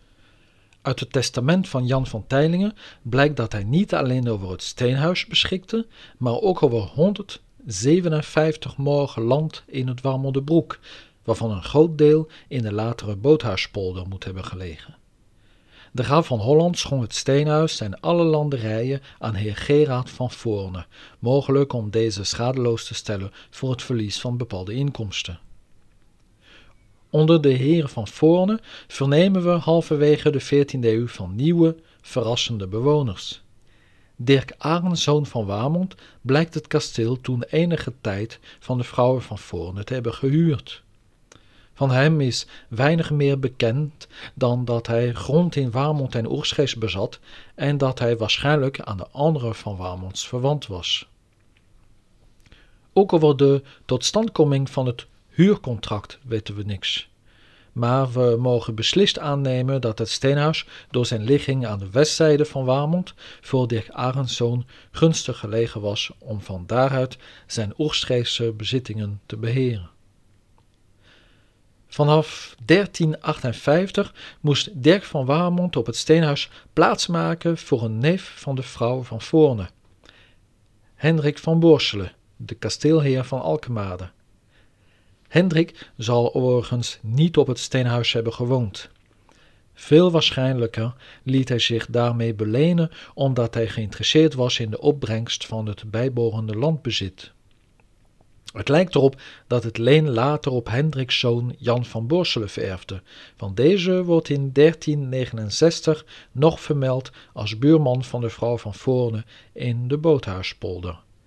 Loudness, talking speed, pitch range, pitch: -22 LUFS, 130 wpm, 110-150 Hz, 125 Hz